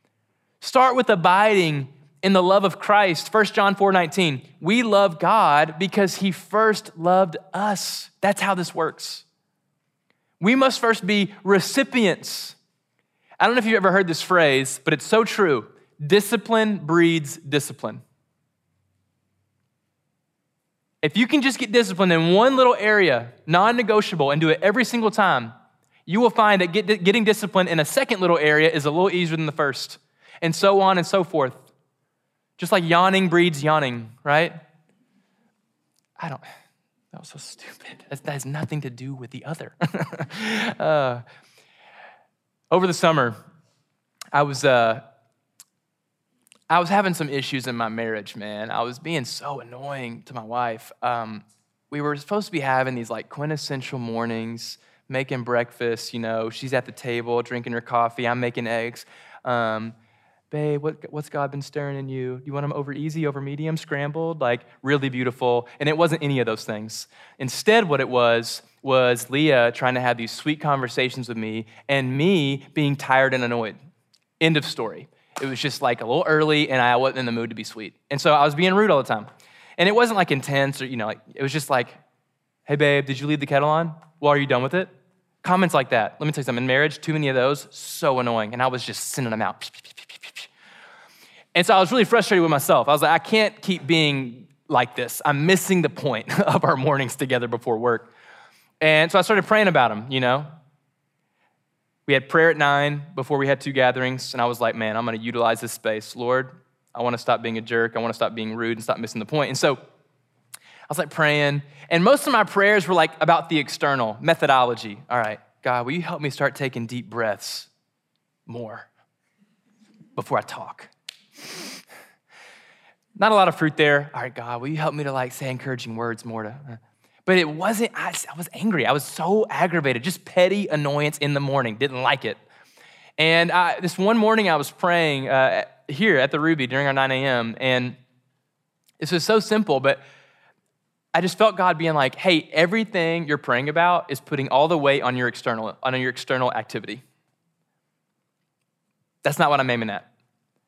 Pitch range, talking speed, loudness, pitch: 125-180 Hz, 190 wpm, -21 LUFS, 145 Hz